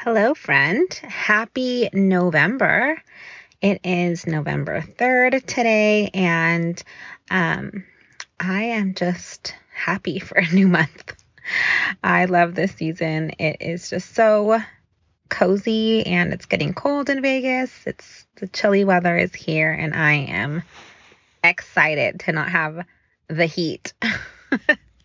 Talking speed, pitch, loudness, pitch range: 115 wpm, 185 Hz, -20 LUFS, 170-225 Hz